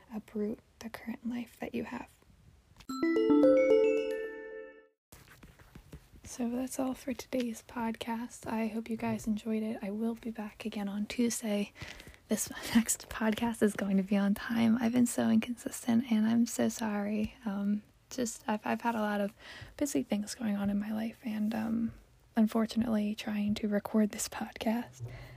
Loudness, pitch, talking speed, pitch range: -32 LUFS, 225 Hz, 155 wpm, 210-240 Hz